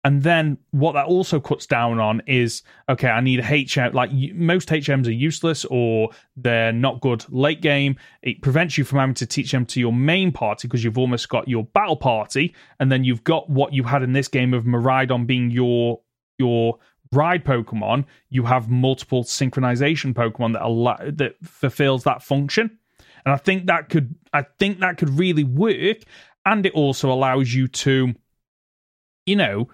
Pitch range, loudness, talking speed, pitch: 125-150 Hz, -20 LUFS, 185 wpm, 135 Hz